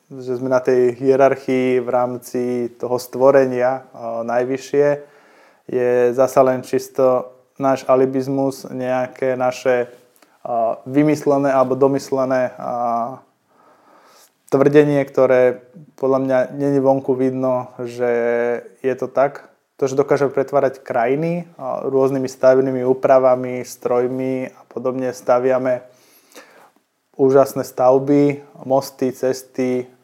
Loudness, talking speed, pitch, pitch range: -18 LUFS, 95 wpm, 130 Hz, 125-135 Hz